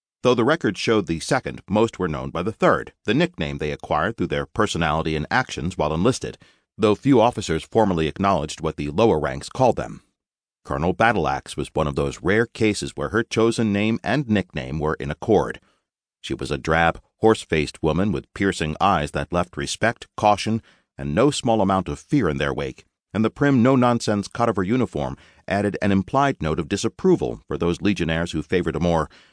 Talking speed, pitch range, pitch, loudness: 195 wpm, 80-110 Hz, 95 Hz, -22 LUFS